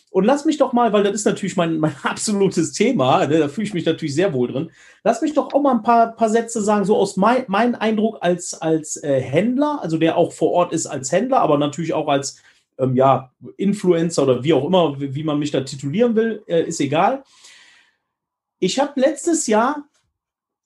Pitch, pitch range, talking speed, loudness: 185 Hz, 155-230 Hz, 215 wpm, -19 LUFS